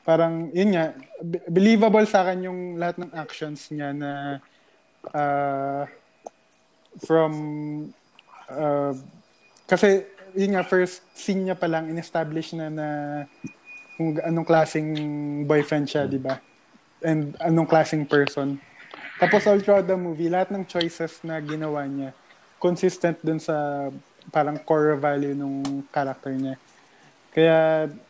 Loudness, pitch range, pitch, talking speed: -24 LUFS, 145-175 Hz, 160 Hz, 120 wpm